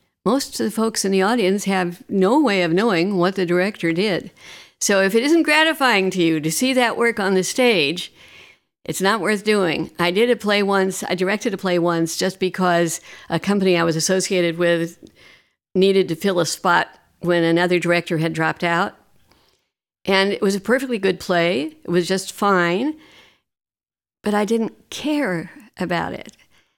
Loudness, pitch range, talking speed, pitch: -19 LUFS, 175-210 Hz, 180 wpm, 190 Hz